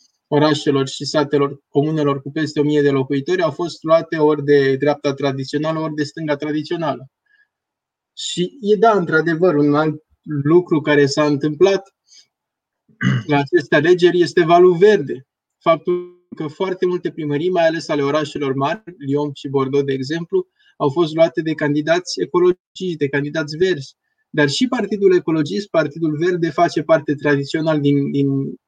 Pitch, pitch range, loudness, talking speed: 155 Hz, 145-180 Hz, -18 LUFS, 150 wpm